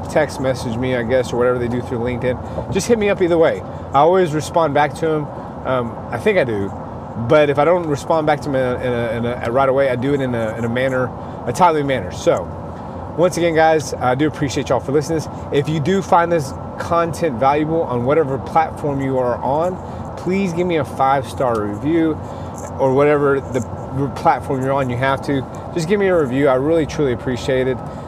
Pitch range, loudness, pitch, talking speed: 120-160 Hz, -18 LUFS, 135 Hz, 225 wpm